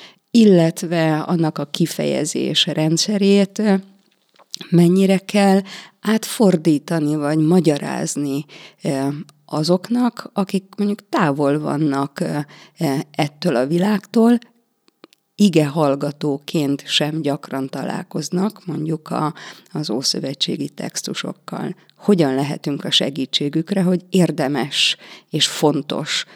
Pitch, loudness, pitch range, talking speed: 170 Hz, -19 LUFS, 150-195 Hz, 80 wpm